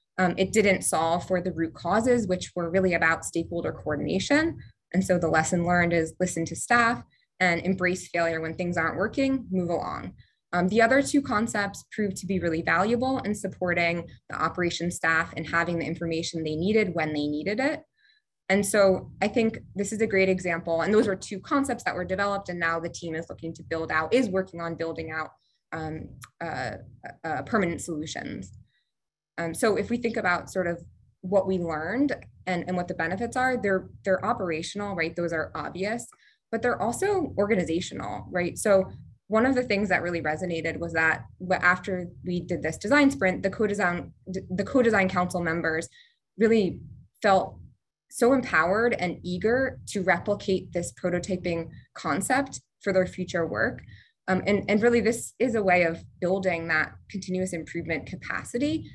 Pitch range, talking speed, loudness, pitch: 170-215 Hz, 175 wpm, -26 LUFS, 185 Hz